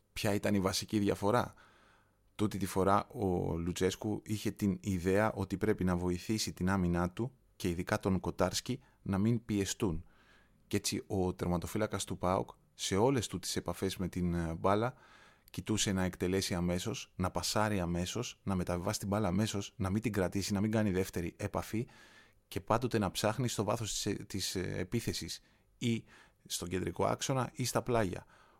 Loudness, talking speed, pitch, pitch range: -35 LUFS, 160 wpm, 100 Hz, 90-110 Hz